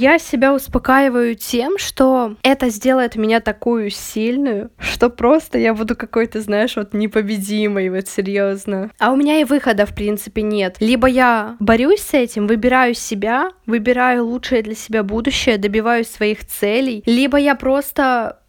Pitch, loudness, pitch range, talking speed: 235 Hz, -16 LUFS, 215-255 Hz, 150 wpm